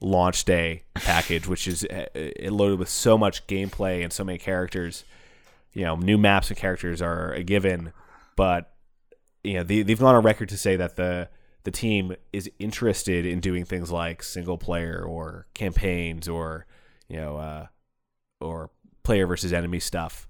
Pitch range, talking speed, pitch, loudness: 85-100 Hz, 165 wpm, 90 Hz, -25 LUFS